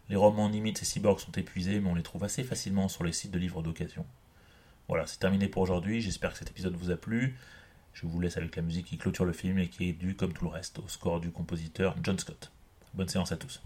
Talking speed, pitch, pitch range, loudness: 260 wpm, 90 Hz, 85-100 Hz, -33 LUFS